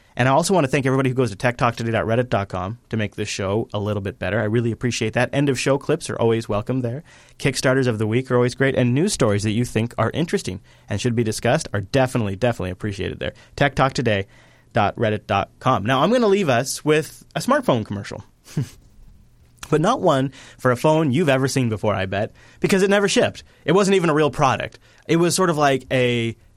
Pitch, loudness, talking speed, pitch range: 125 Hz, -21 LUFS, 210 wpm, 110-140 Hz